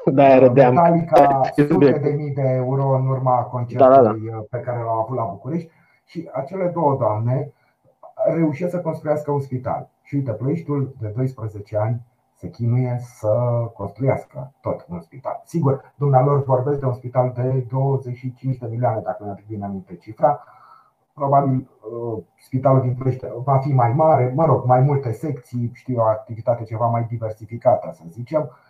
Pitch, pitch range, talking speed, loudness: 130 Hz, 120-140 Hz, 155 wpm, -20 LUFS